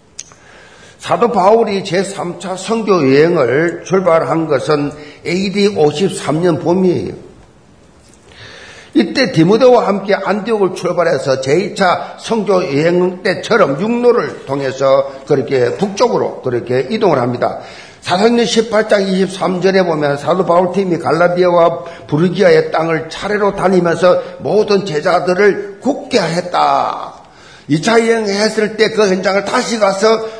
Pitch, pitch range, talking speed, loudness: 185 Hz, 165-210 Hz, 255 characters per minute, -13 LUFS